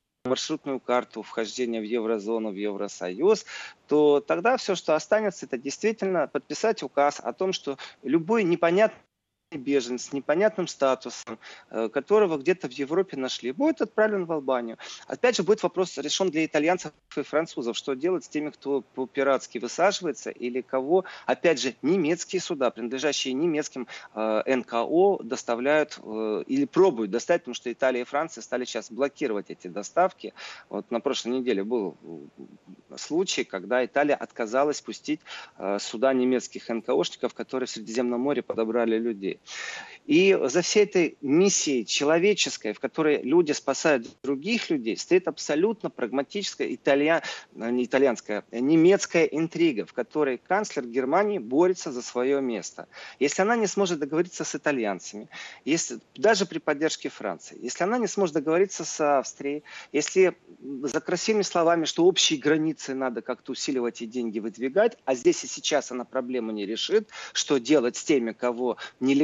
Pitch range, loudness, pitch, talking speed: 125-180 Hz, -26 LUFS, 145 Hz, 145 wpm